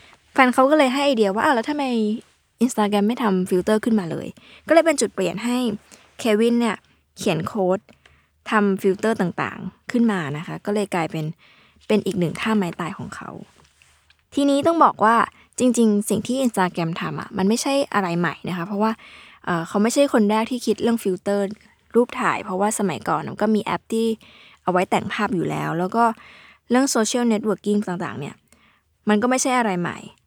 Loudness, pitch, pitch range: -21 LUFS, 215 Hz, 190-235 Hz